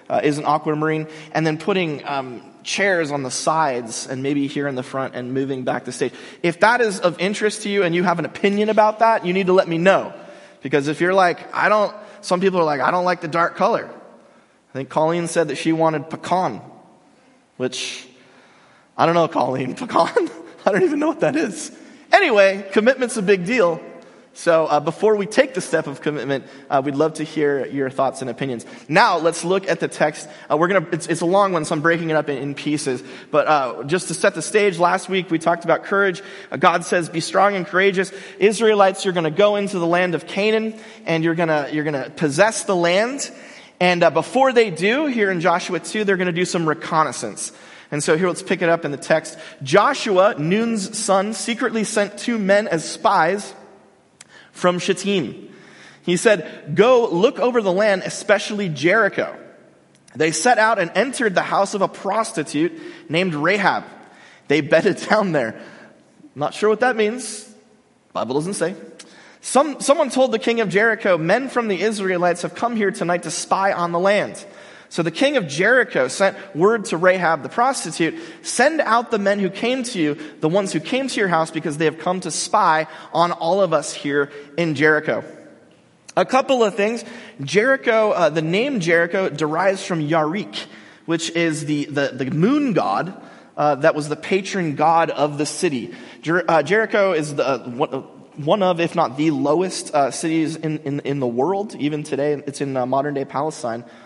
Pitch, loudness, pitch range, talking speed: 175 Hz, -19 LUFS, 155-205 Hz, 195 wpm